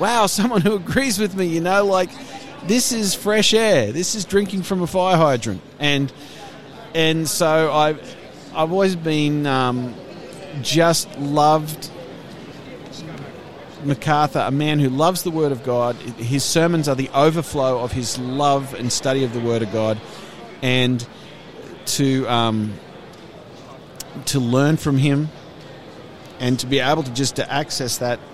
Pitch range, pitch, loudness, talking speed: 130-175 Hz, 150 Hz, -19 LUFS, 150 wpm